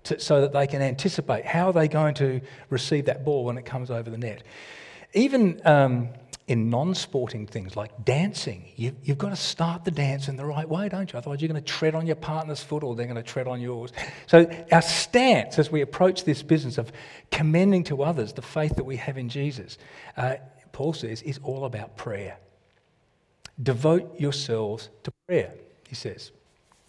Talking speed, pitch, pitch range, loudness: 195 wpm, 140 Hz, 125-160 Hz, -25 LUFS